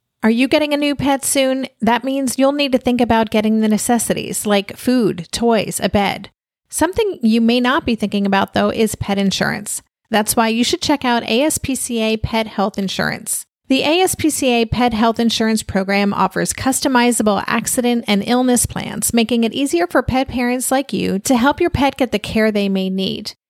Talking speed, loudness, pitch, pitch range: 185 wpm, -17 LUFS, 235 Hz, 210-265 Hz